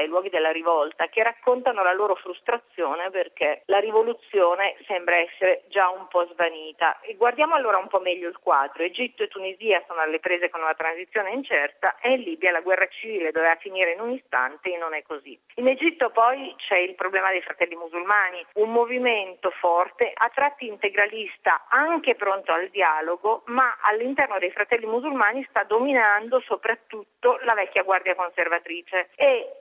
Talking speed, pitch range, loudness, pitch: 170 wpm, 175-240 Hz, -23 LUFS, 195 Hz